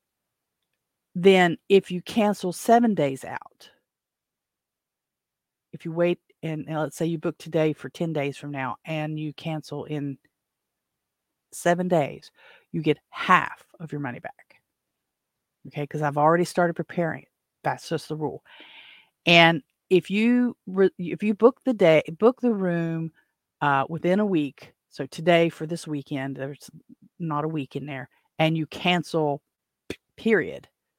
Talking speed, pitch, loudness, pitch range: 150 wpm, 165 Hz, -24 LUFS, 145-180 Hz